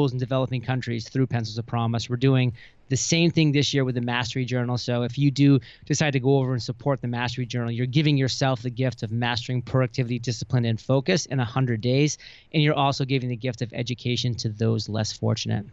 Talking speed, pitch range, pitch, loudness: 220 wpm, 120-135 Hz, 125 Hz, -24 LUFS